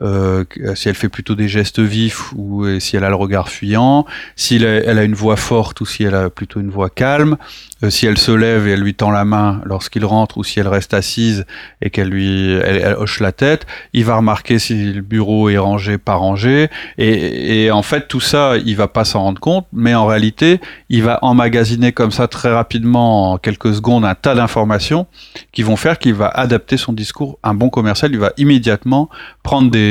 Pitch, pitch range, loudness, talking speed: 110 Hz, 100-120 Hz, -14 LUFS, 220 wpm